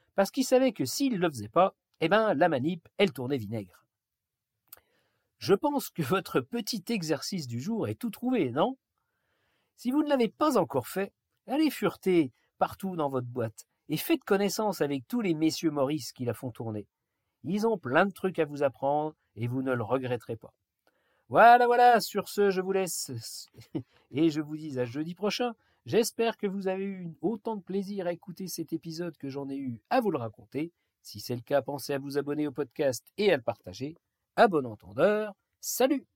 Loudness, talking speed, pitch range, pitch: -29 LUFS, 195 wpm, 135-205 Hz, 165 Hz